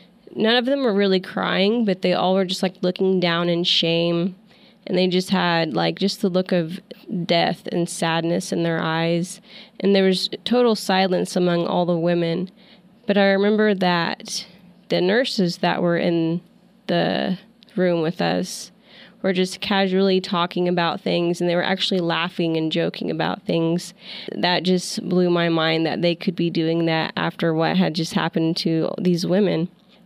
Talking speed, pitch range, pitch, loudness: 175 wpm, 170-195 Hz, 185 Hz, -21 LUFS